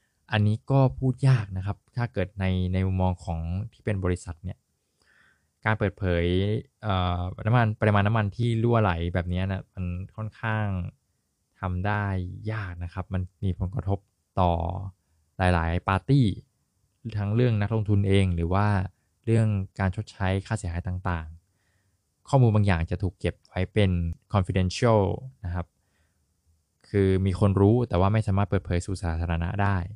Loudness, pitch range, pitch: -26 LUFS, 90-105 Hz, 95 Hz